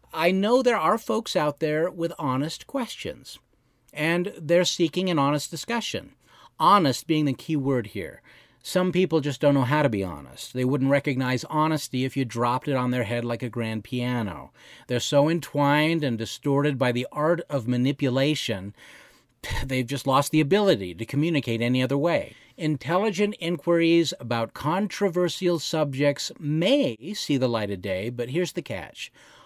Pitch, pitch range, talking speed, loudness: 145 Hz, 125-170 Hz, 165 wpm, -25 LUFS